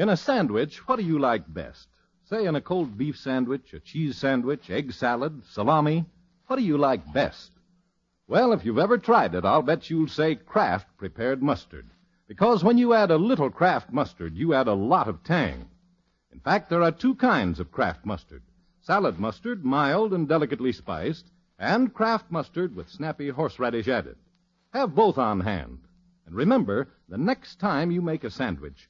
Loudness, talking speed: -25 LUFS, 180 wpm